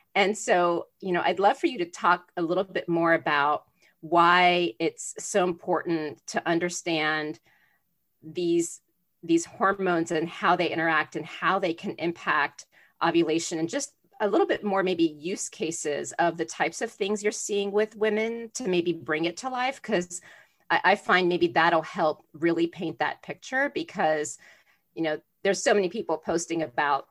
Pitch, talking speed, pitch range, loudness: 175 Hz, 175 wpm, 165-195 Hz, -26 LUFS